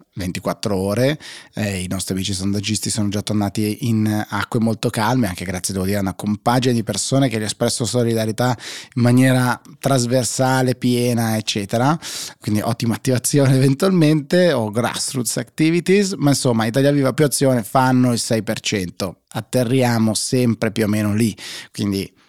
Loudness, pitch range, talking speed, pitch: -19 LUFS, 105-130 Hz, 150 wpm, 115 Hz